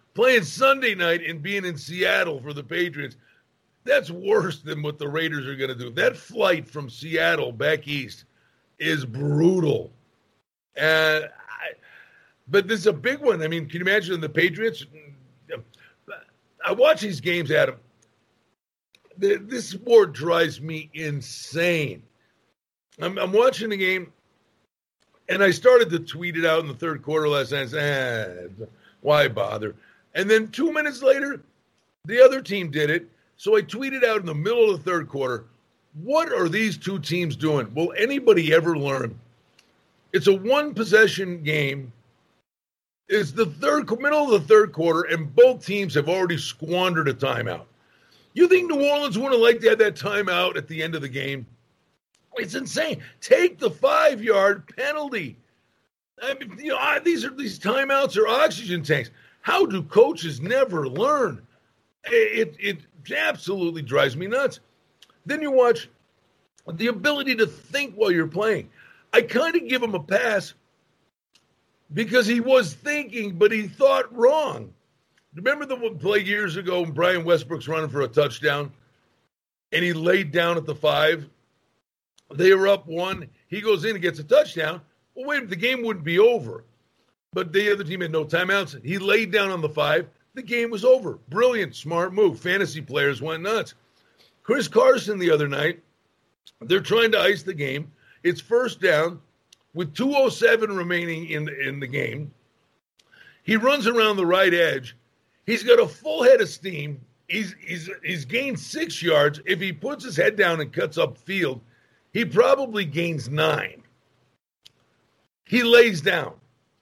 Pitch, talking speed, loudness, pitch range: 180 Hz, 165 wpm, -22 LUFS, 155-245 Hz